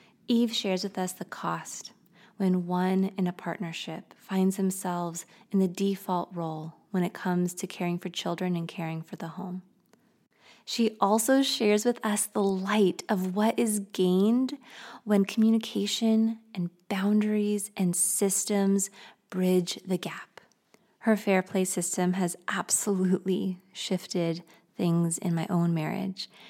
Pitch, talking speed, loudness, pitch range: 190 Hz, 140 wpm, -28 LUFS, 180-215 Hz